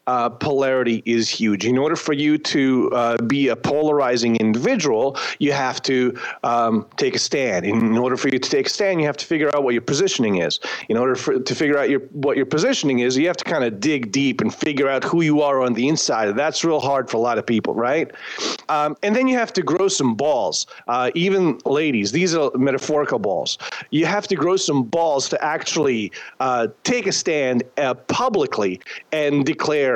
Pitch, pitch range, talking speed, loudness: 140 Hz, 125-160 Hz, 210 wpm, -20 LUFS